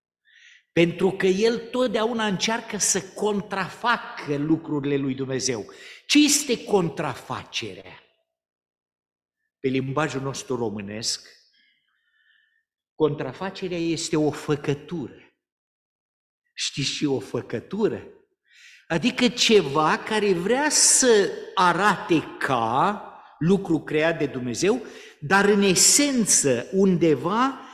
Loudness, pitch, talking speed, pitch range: -22 LUFS, 190 Hz, 85 wpm, 150-245 Hz